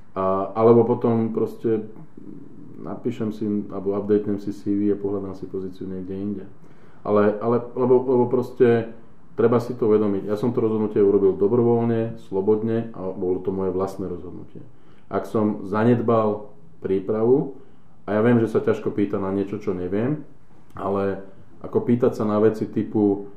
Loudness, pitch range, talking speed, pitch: -22 LUFS, 100-115 Hz, 150 wpm, 105 Hz